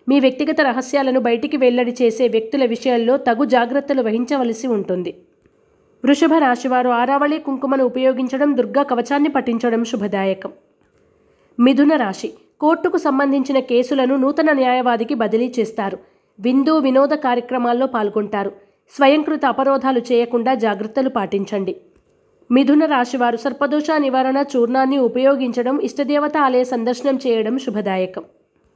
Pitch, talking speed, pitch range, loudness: 260 Hz, 105 wpm, 240-280 Hz, -17 LUFS